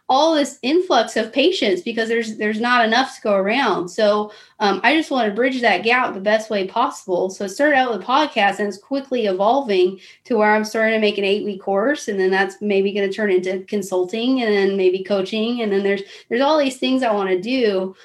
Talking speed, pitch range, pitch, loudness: 235 wpm, 195-245 Hz, 215 Hz, -19 LUFS